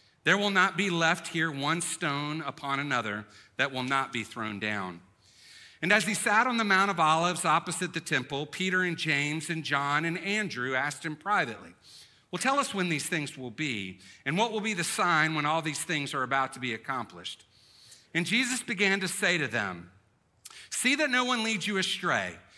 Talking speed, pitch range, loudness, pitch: 200 wpm, 135-190 Hz, -28 LUFS, 160 Hz